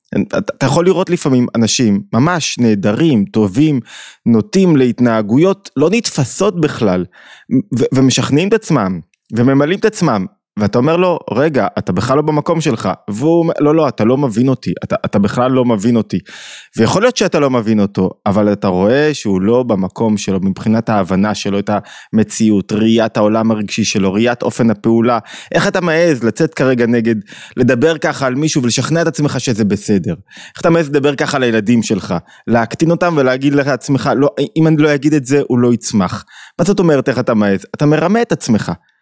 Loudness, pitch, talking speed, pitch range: -14 LUFS, 130 Hz, 175 wpm, 110-155 Hz